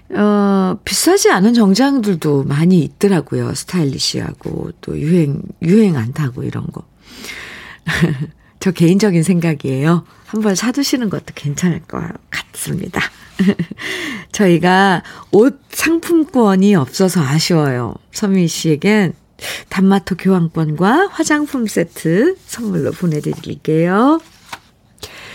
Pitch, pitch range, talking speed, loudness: 185 Hz, 160-215 Hz, 240 characters per minute, -15 LUFS